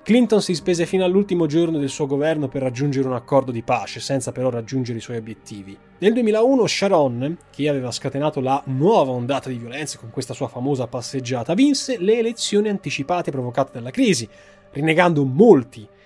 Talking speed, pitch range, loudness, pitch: 170 wpm, 125-175 Hz, -20 LUFS, 140 Hz